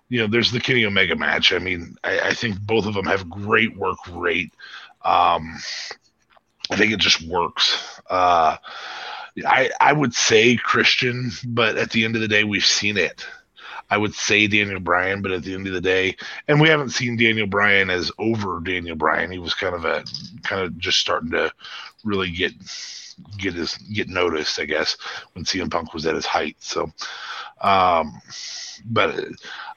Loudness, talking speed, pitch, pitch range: -20 LUFS, 185 wpm, 105 Hz, 95-115 Hz